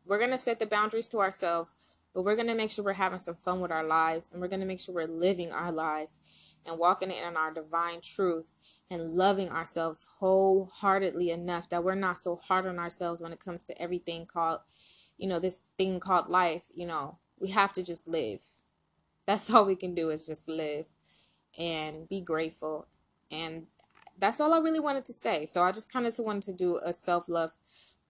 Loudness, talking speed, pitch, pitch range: -30 LUFS, 210 wpm, 175 Hz, 165-190 Hz